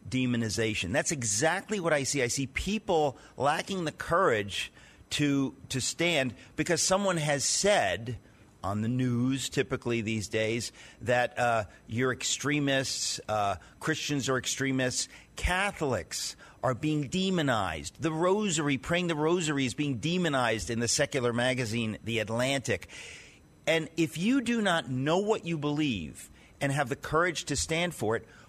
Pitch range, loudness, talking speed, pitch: 120-160 Hz, -29 LUFS, 145 wpm, 135 Hz